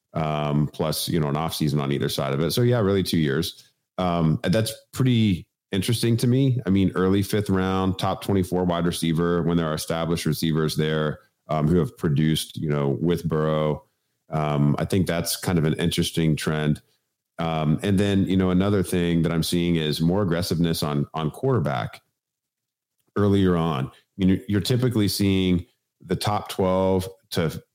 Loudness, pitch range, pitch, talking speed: -23 LUFS, 80-95 Hz, 85 Hz, 180 wpm